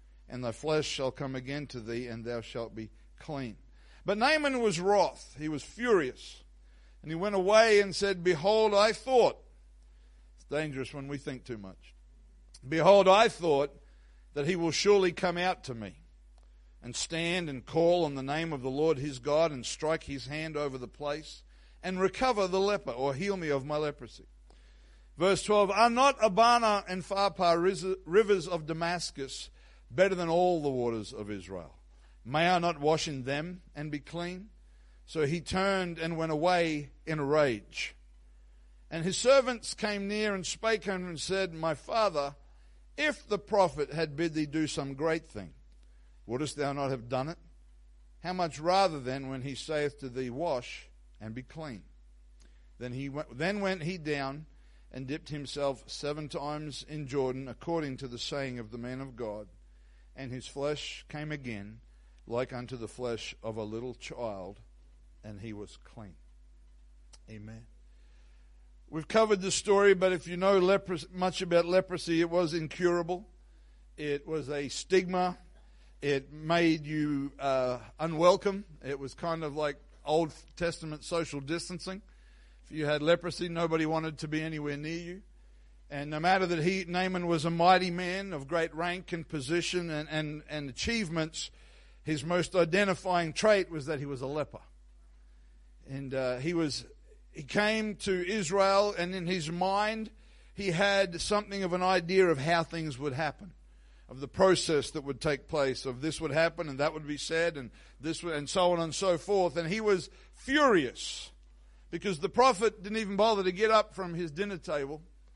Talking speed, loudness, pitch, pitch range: 175 wpm, -30 LUFS, 155 Hz, 125-180 Hz